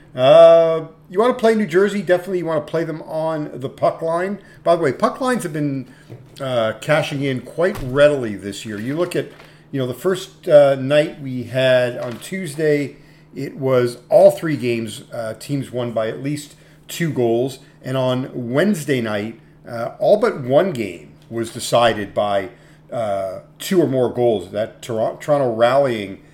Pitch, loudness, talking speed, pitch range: 145 Hz, -18 LUFS, 180 wpm, 125-165 Hz